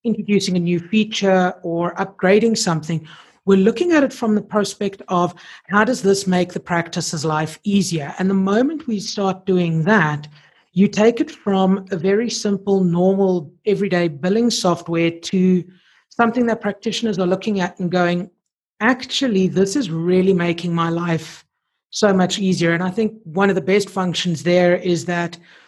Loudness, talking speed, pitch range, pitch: -19 LUFS, 165 wpm, 175-210 Hz, 190 Hz